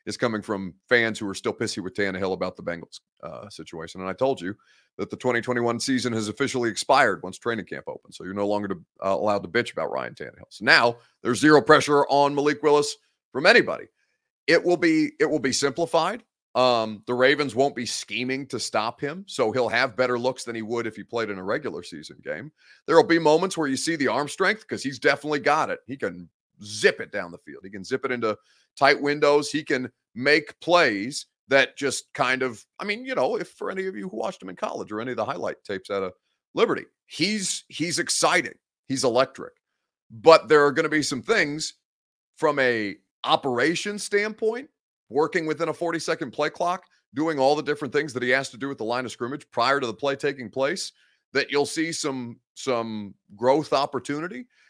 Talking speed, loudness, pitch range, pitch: 210 wpm, -24 LUFS, 115-155 Hz, 135 Hz